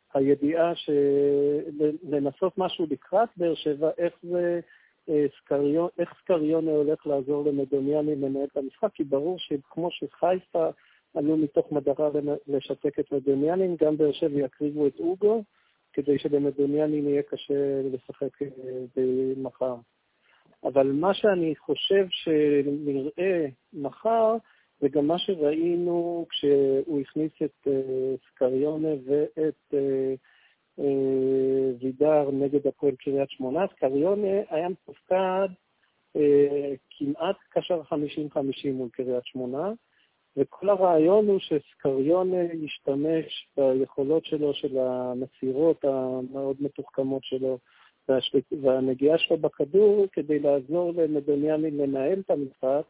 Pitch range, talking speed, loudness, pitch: 140-165 Hz, 105 wpm, -26 LUFS, 145 Hz